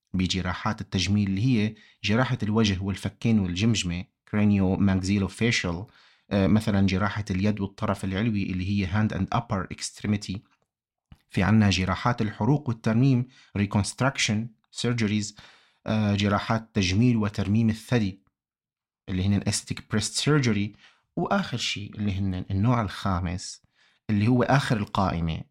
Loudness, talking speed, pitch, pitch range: -26 LUFS, 110 wpm, 105 Hz, 95-110 Hz